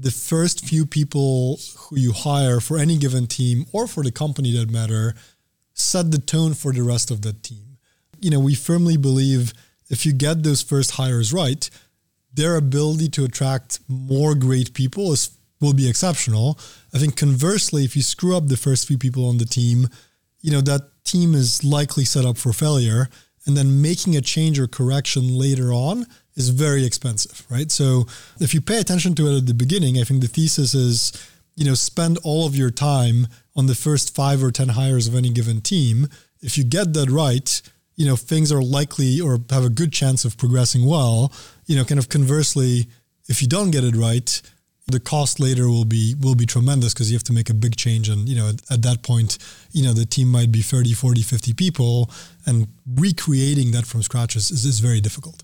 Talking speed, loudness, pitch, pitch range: 205 wpm, -19 LUFS, 130 Hz, 120-150 Hz